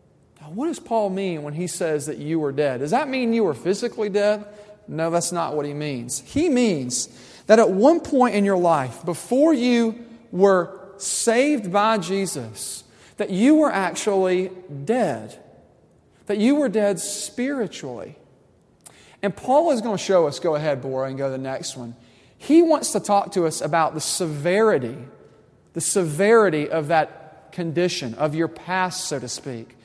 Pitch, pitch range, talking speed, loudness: 185 Hz, 155-220 Hz, 170 wpm, -21 LUFS